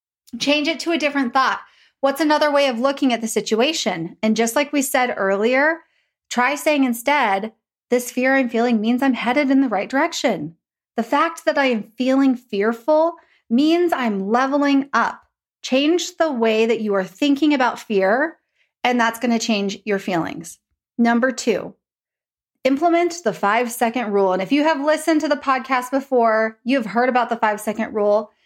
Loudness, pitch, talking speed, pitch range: -19 LUFS, 255 Hz, 175 wpm, 225-290 Hz